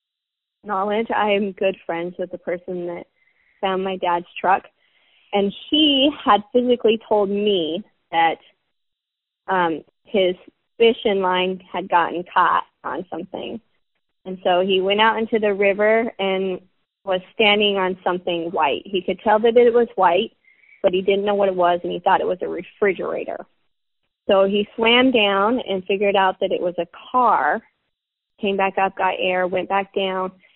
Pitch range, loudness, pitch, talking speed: 185-220 Hz, -20 LUFS, 195 Hz, 165 wpm